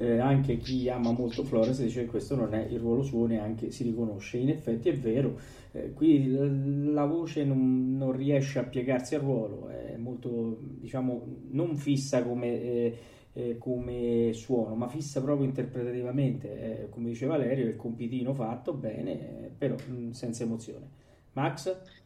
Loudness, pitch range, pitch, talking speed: -31 LUFS, 115-135 Hz, 125 Hz, 160 wpm